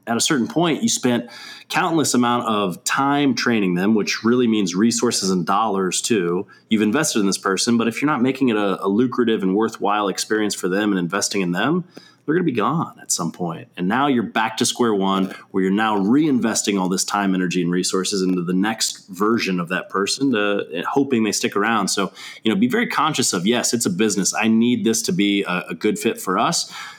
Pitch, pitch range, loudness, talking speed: 105 Hz, 95-120 Hz, -20 LUFS, 225 wpm